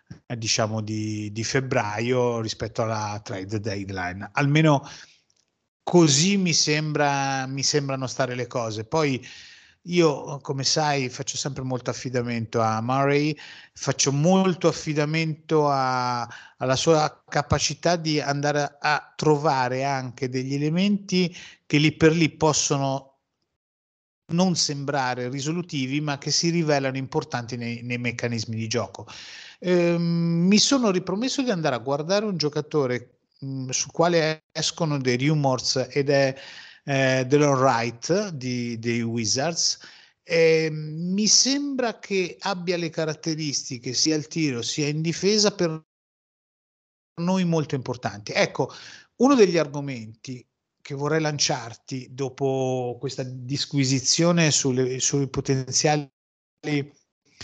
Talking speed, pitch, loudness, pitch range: 115 wpm, 140 Hz, -23 LUFS, 125-160 Hz